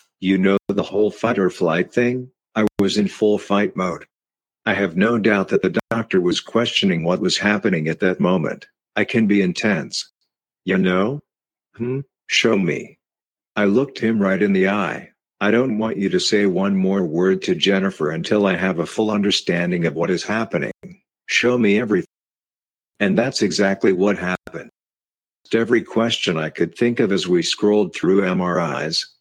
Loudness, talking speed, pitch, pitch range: -19 LUFS, 175 wpm, 100 Hz, 95-110 Hz